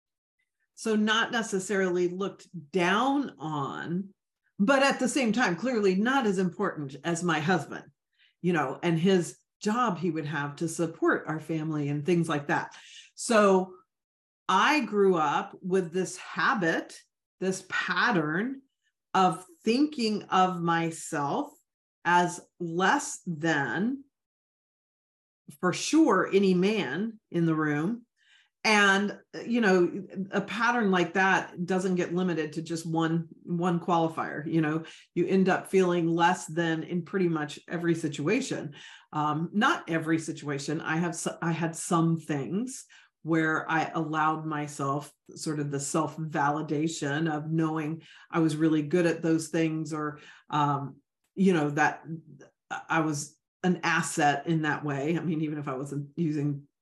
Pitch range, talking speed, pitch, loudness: 155-190 Hz, 140 wpm, 170 Hz, -28 LUFS